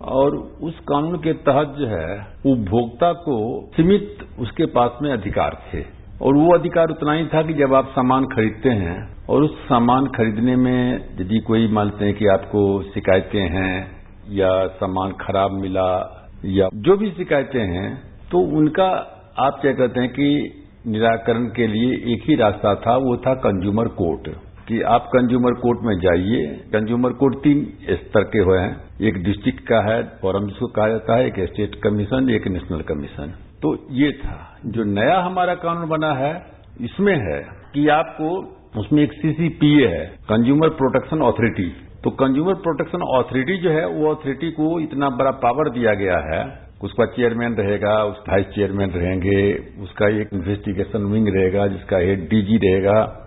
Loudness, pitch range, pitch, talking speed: -19 LUFS, 100-140 Hz, 115 Hz, 165 wpm